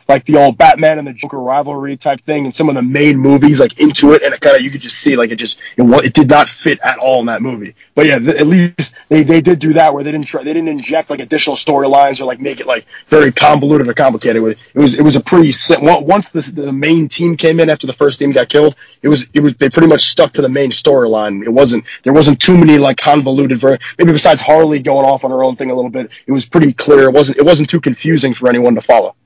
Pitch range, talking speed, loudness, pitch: 135-155 Hz, 280 wpm, -10 LUFS, 145 Hz